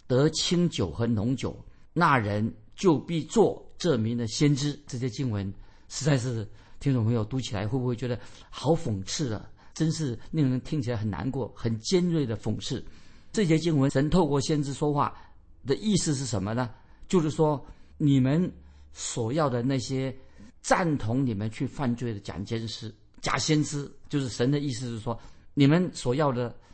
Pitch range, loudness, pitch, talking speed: 110-145 Hz, -28 LUFS, 130 Hz, 245 characters per minute